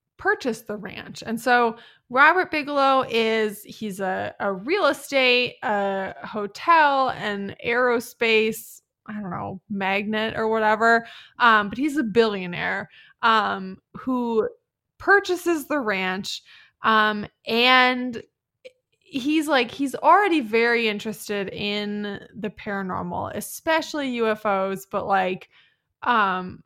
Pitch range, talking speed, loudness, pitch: 205-270 Hz, 110 wpm, -22 LUFS, 225 Hz